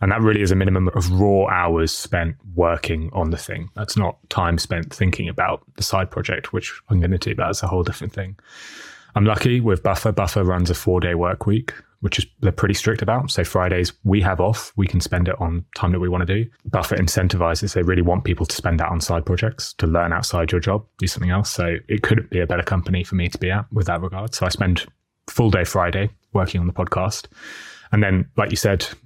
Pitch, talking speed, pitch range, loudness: 95 Hz, 235 wpm, 90-105 Hz, -21 LUFS